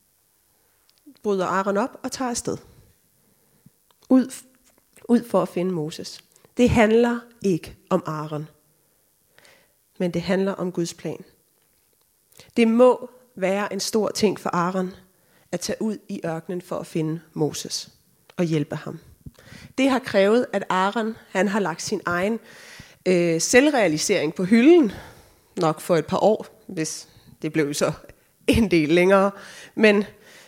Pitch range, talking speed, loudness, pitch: 165-225 Hz, 140 wpm, -22 LUFS, 190 Hz